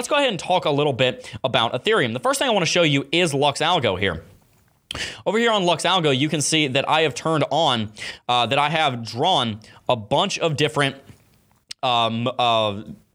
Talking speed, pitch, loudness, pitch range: 210 wpm, 145 Hz, -20 LUFS, 120-165 Hz